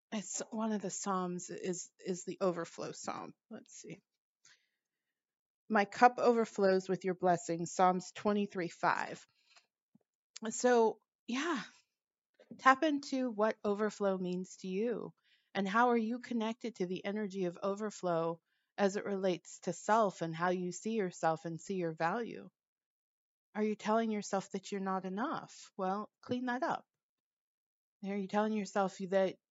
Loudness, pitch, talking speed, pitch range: -35 LUFS, 200 Hz, 145 wpm, 185-225 Hz